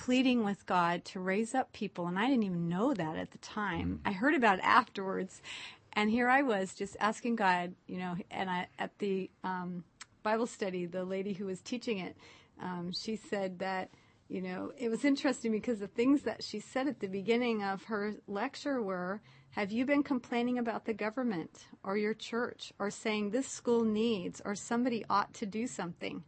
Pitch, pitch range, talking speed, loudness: 210 Hz, 190-240 Hz, 195 wpm, -34 LUFS